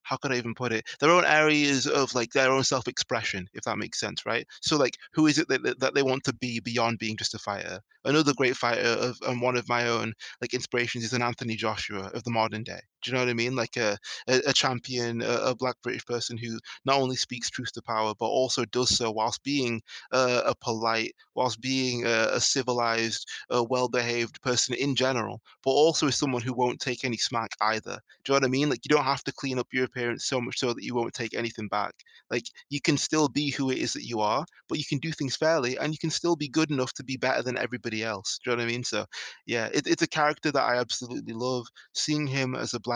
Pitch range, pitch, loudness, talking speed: 115-135 Hz, 125 Hz, -27 LUFS, 255 wpm